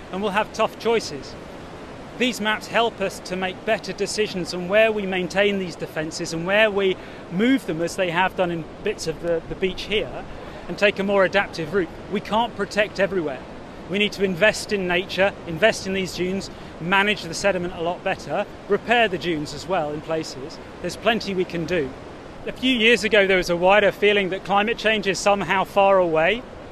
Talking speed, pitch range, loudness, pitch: 200 wpm, 180-210 Hz, -22 LUFS, 195 Hz